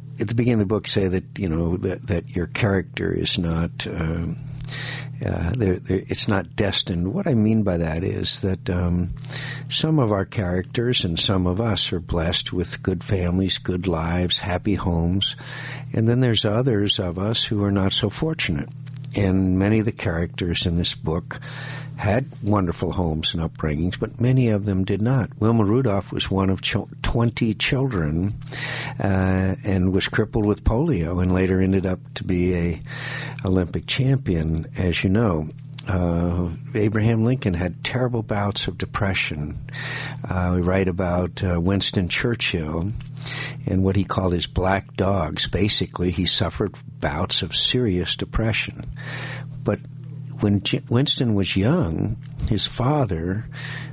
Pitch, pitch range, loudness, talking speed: 105 Hz, 90-130 Hz, -23 LUFS, 155 wpm